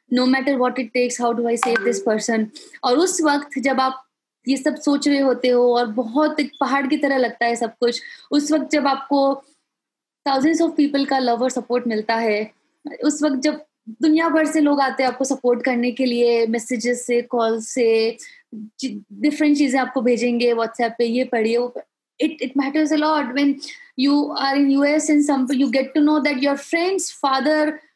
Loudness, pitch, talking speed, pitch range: -20 LUFS, 270 Hz, 165 wpm, 245-295 Hz